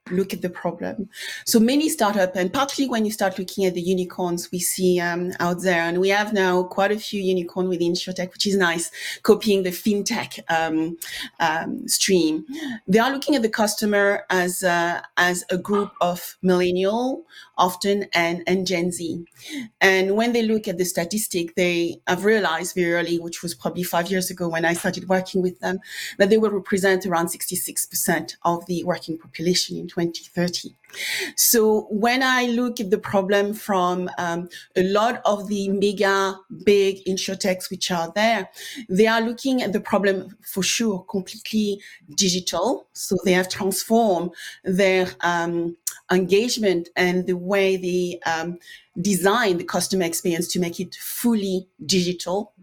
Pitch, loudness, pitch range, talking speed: 185 Hz, -22 LUFS, 175-205 Hz, 165 wpm